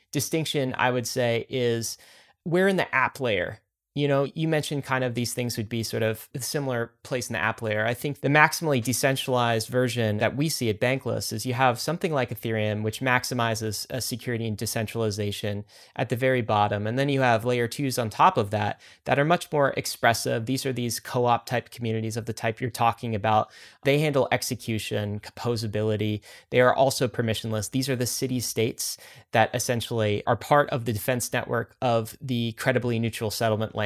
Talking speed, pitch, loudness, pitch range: 195 wpm, 120 Hz, -26 LUFS, 110-130 Hz